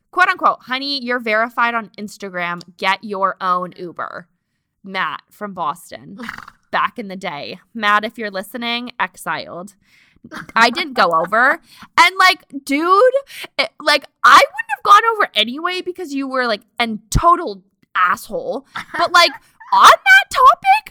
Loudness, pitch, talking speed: -15 LUFS, 245 Hz, 145 wpm